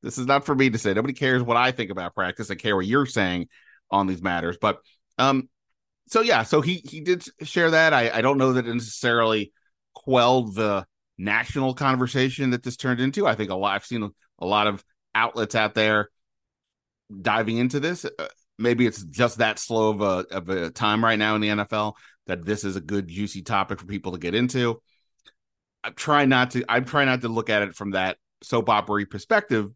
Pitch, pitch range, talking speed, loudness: 115 Hz, 105-130 Hz, 215 wpm, -23 LUFS